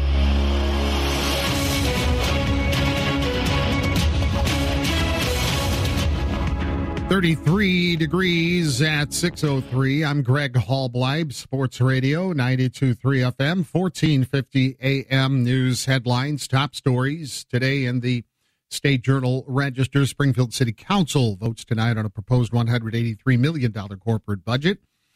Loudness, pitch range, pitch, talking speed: -22 LUFS, 95-140 Hz, 125 Hz, 85 wpm